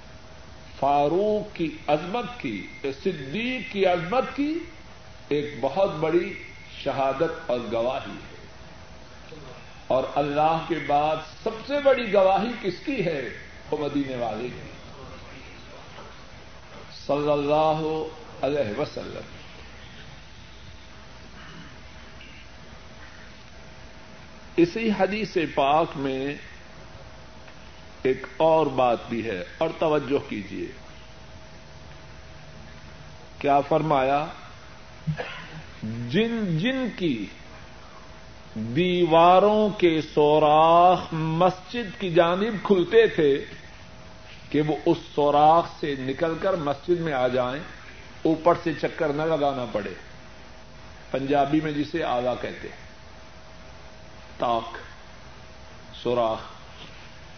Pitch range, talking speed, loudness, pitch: 140-185 Hz, 85 wpm, -24 LUFS, 155 Hz